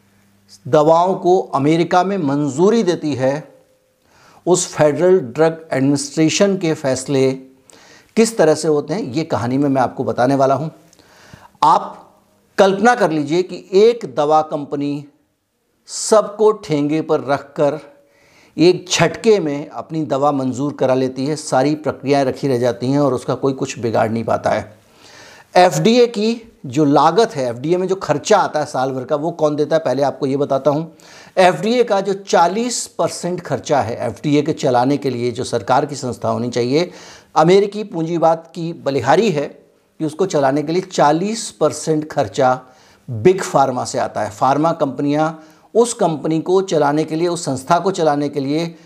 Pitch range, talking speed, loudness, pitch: 135-175 Hz, 165 wpm, -17 LUFS, 155 Hz